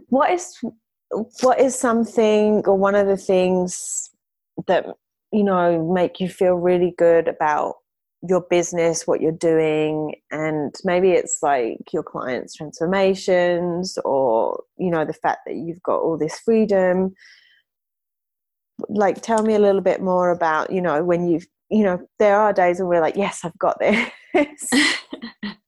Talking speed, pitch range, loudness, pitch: 155 wpm, 170-215 Hz, -20 LUFS, 185 Hz